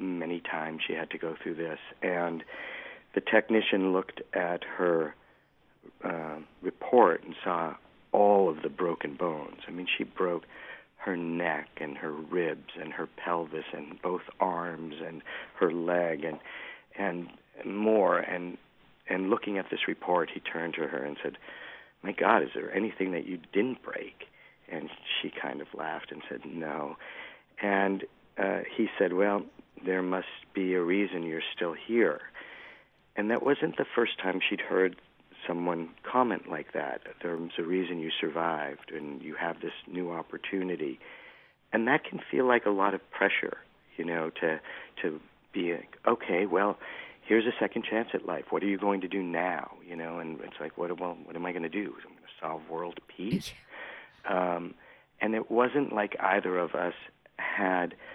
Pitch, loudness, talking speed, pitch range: 90 Hz, -31 LUFS, 170 wpm, 85-100 Hz